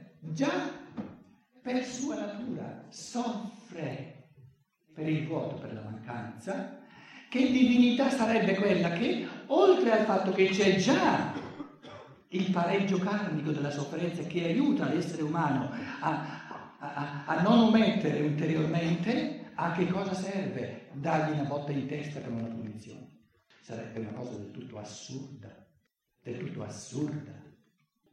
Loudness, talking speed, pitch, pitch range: -30 LUFS, 125 wpm, 165 Hz, 140-215 Hz